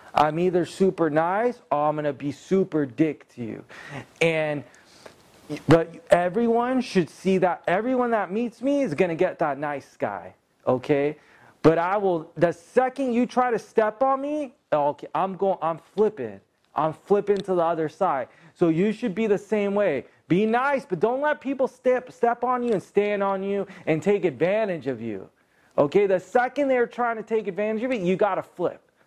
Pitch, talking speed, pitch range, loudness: 190 Hz, 195 wpm, 160-235 Hz, -24 LUFS